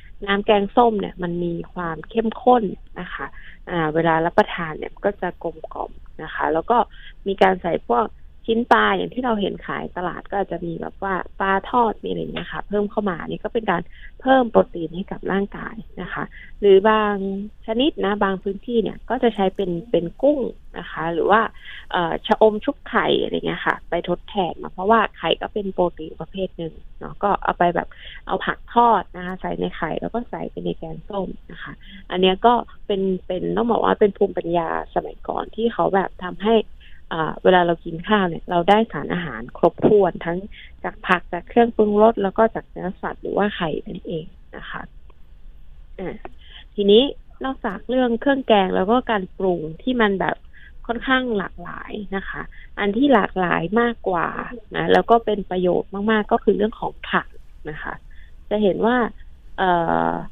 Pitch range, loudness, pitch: 175-225 Hz, -21 LUFS, 200 Hz